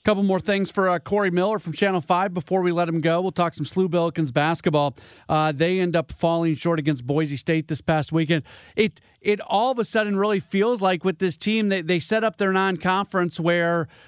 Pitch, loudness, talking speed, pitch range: 180 Hz, -22 LUFS, 225 wpm, 165-195 Hz